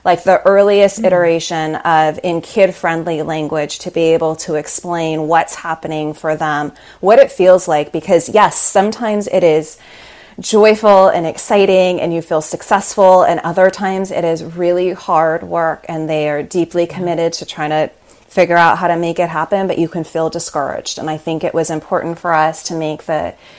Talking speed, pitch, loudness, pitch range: 185 wpm, 165 Hz, -14 LUFS, 160-185 Hz